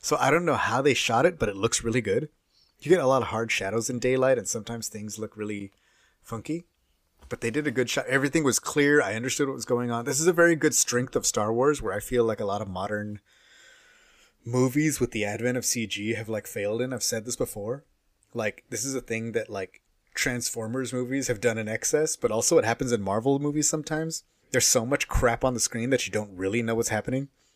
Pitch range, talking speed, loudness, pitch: 110-135 Hz, 235 wpm, -26 LUFS, 120 Hz